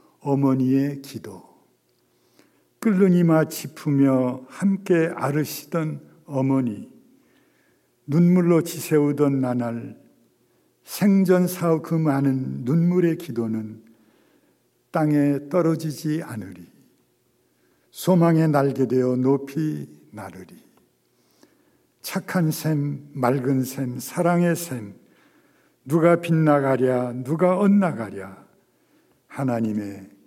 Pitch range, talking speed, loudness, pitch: 125-165 Hz, 180 characters per minute, -22 LUFS, 145 Hz